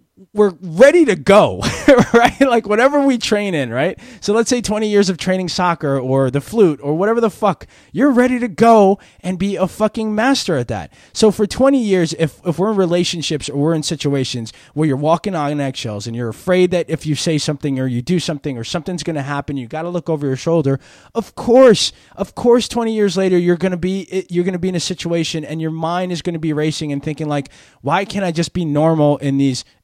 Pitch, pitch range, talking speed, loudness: 175 Hz, 150-205 Hz, 225 wpm, -16 LUFS